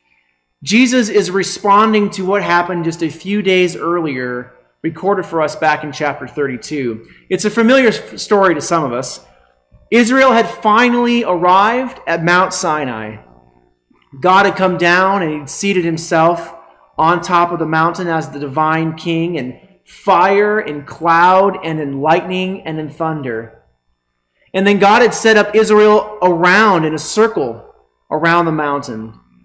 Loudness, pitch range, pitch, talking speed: -14 LUFS, 145-195 Hz, 165 Hz, 150 wpm